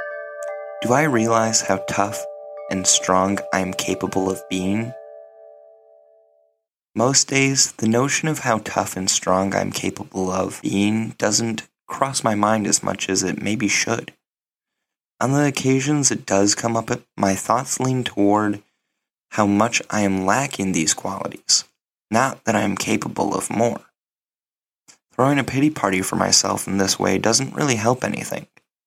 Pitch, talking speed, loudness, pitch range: 100 Hz, 155 wpm, -20 LUFS, 95-115 Hz